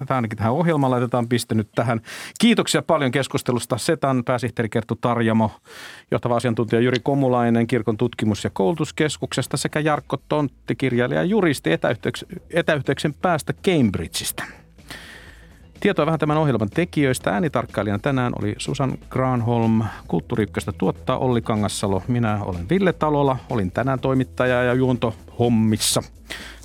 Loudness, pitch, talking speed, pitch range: -21 LUFS, 125 Hz, 130 wpm, 115-140 Hz